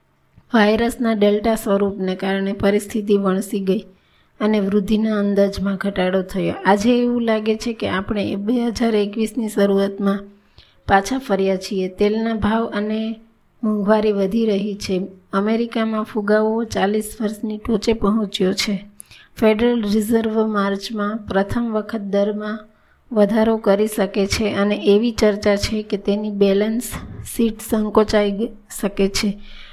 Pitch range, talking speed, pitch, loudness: 200-220 Hz, 120 wpm, 210 Hz, -19 LUFS